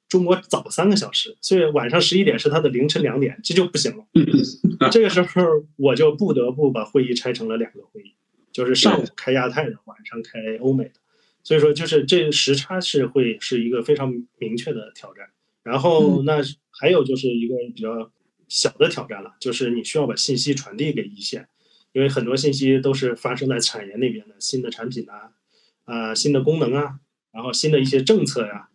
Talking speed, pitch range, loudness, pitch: 305 characters per minute, 125-160 Hz, -20 LUFS, 140 Hz